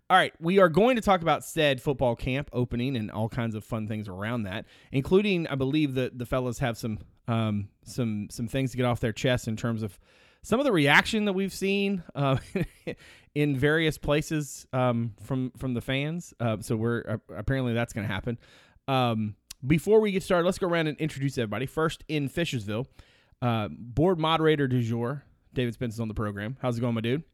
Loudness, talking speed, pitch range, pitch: -27 LUFS, 205 wpm, 115-150 Hz, 130 Hz